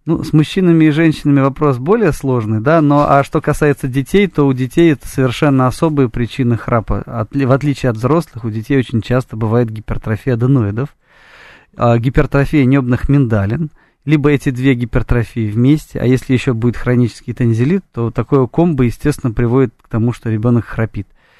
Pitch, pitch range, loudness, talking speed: 130 Hz, 120-145 Hz, -14 LUFS, 165 wpm